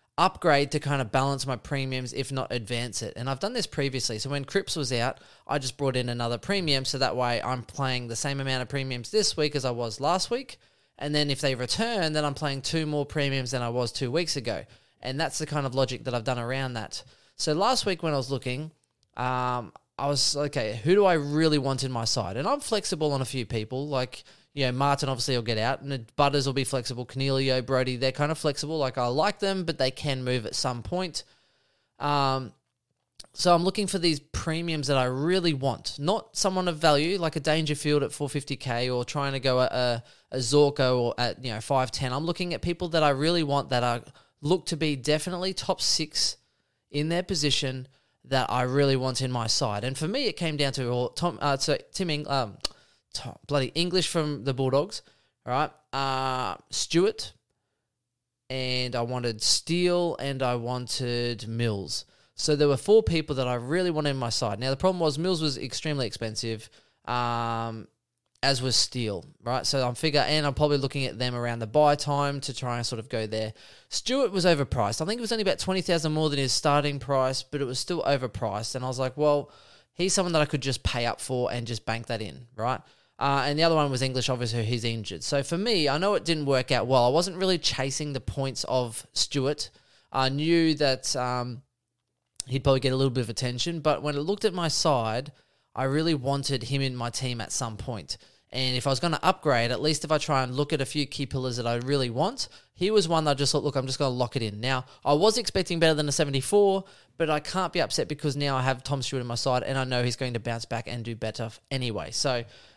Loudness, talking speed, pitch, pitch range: -27 LUFS, 230 wpm, 135 Hz, 125-150 Hz